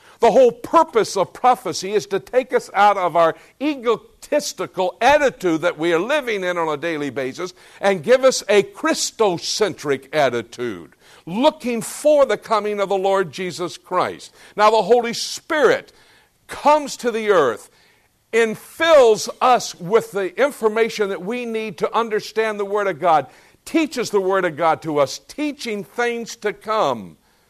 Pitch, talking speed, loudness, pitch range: 215 Hz, 155 wpm, -19 LUFS, 185-255 Hz